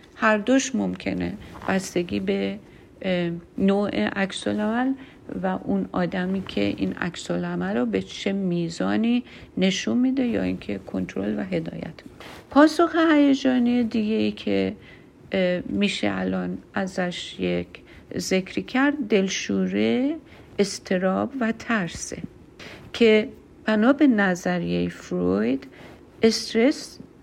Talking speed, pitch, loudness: 100 wpm, 190 Hz, -24 LUFS